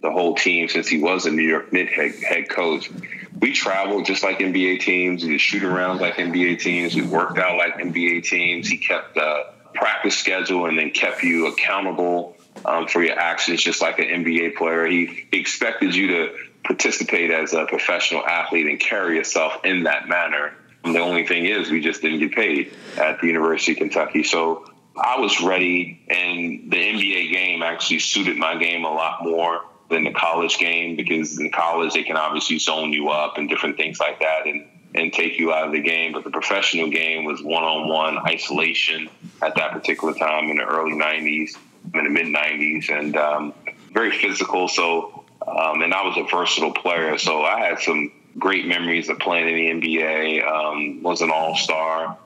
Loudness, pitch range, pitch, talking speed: -20 LUFS, 80-85 Hz, 80 Hz, 195 wpm